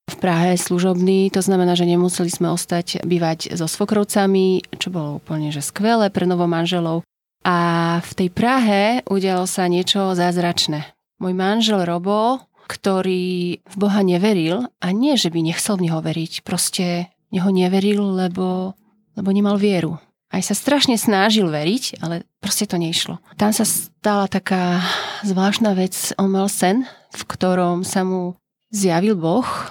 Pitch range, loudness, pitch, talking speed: 175-205 Hz, -19 LUFS, 185 Hz, 150 wpm